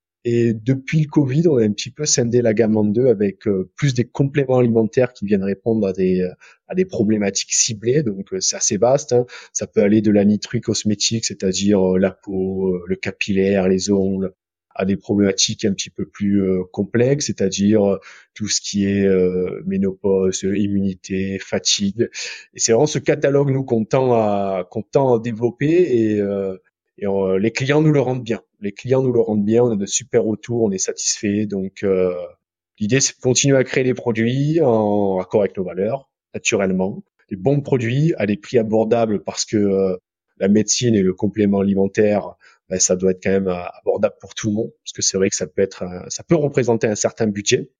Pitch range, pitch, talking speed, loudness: 95-120 Hz, 105 Hz, 200 wpm, -19 LUFS